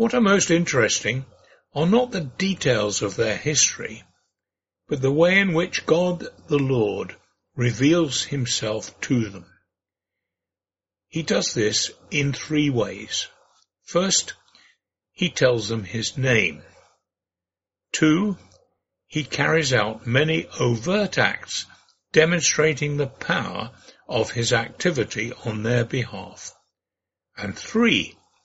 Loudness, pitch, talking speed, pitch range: -22 LUFS, 135 Hz, 110 wpm, 110-165 Hz